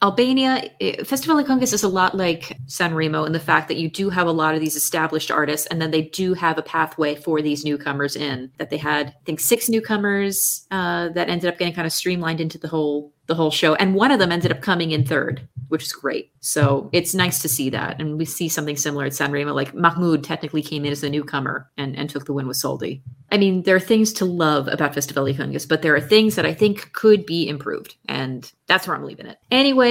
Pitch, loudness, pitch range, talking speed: 160 Hz, -20 LUFS, 145-185 Hz, 245 wpm